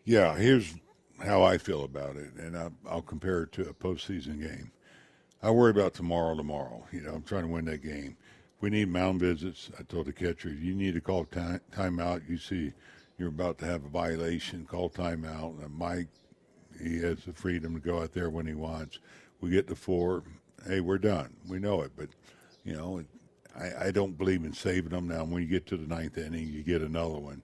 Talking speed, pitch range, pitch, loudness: 215 wpm, 80-95 Hz, 85 Hz, -32 LUFS